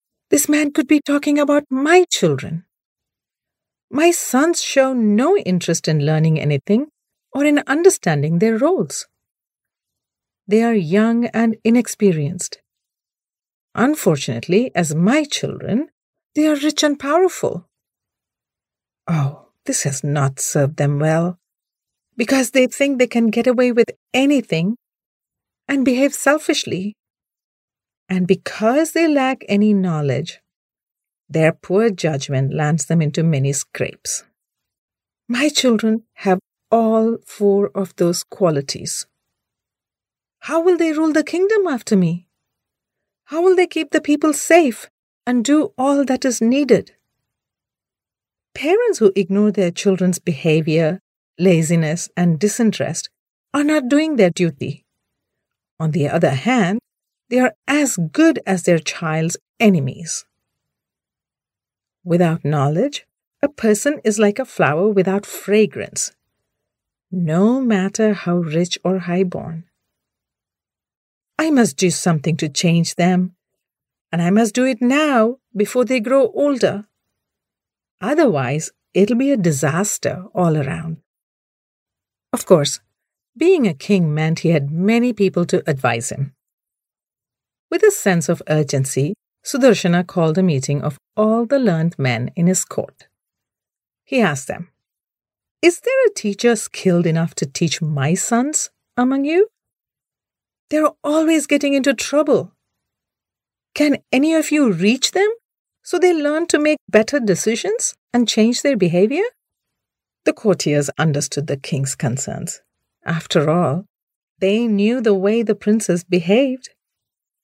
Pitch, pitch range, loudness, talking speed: 205 Hz, 165-270 Hz, -17 LUFS, 125 wpm